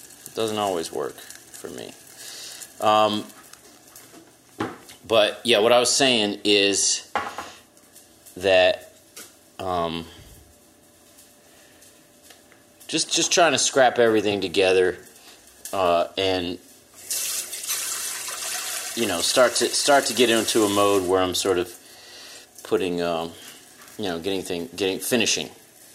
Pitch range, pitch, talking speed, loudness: 90-110 Hz, 100 Hz, 105 wpm, -21 LUFS